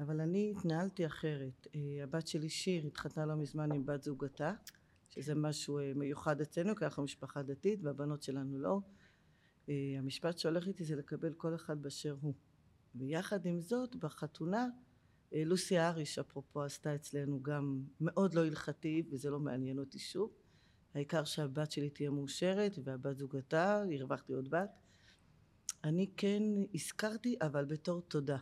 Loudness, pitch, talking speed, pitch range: -39 LUFS, 150 Hz, 150 wpm, 140-170 Hz